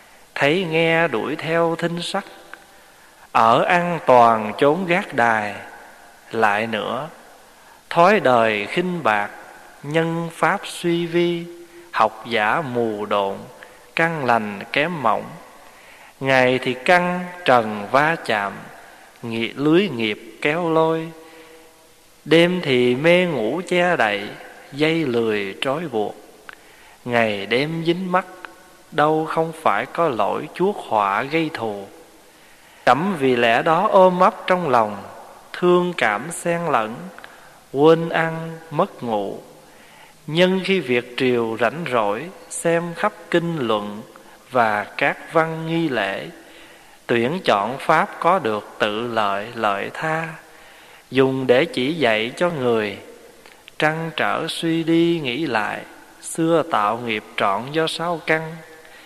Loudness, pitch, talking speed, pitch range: -20 LUFS, 160 Hz, 125 wpm, 120-170 Hz